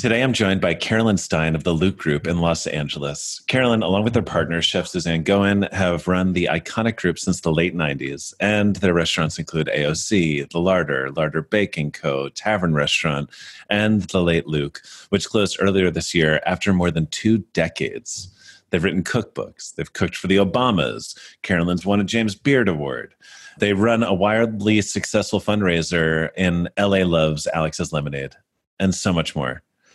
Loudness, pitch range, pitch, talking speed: -20 LUFS, 80-100 Hz, 90 Hz, 170 wpm